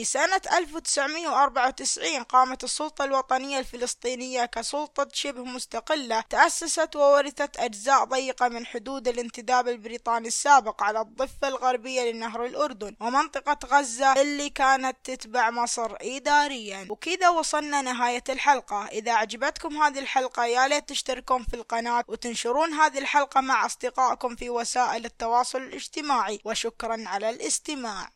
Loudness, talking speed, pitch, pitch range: -25 LUFS, 120 wpm, 255 Hz, 235-285 Hz